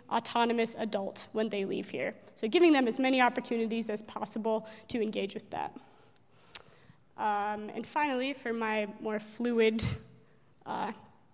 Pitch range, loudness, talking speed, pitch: 215-240 Hz, -31 LUFS, 140 wpm, 225 Hz